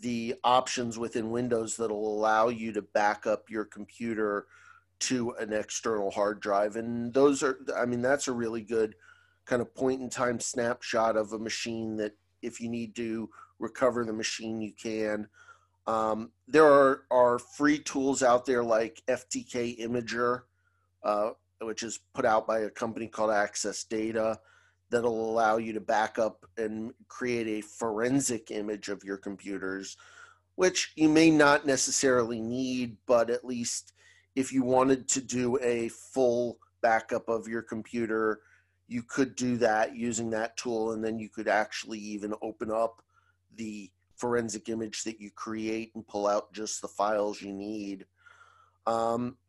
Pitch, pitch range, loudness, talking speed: 115 Hz, 105-120 Hz, -29 LUFS, 155 wpm